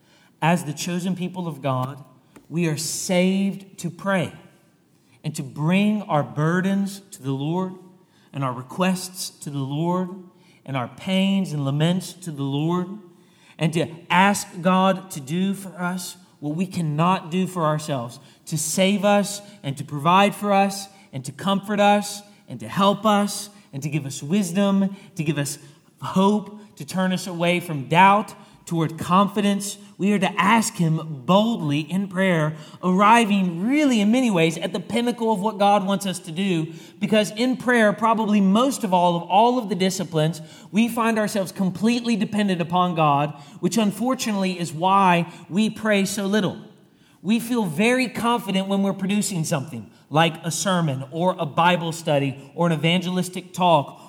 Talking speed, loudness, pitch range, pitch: 165 wpm, -22 LUFS, 165-200 Hz, 185 Hz